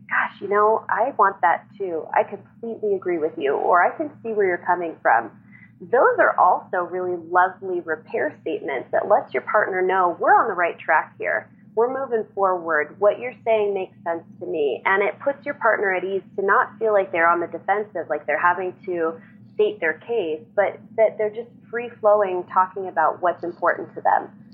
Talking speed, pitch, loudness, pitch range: 200 wpm, 195 Hz, -22 LUFS, 180-225 Hz